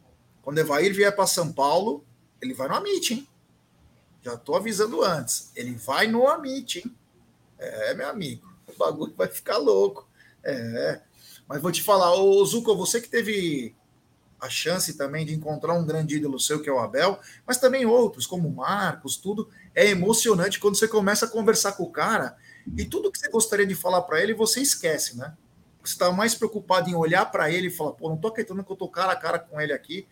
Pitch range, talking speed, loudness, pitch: 155-225 Hz, 205 wpm, -24 LUFS, 190 Hz